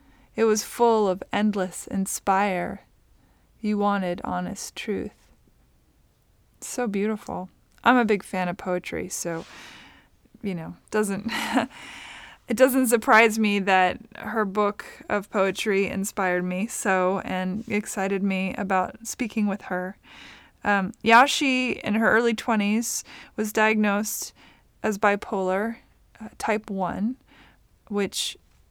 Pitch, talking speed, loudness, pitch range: 205 Hz, 115 wpm, -24 LUFS, 190-220 Hz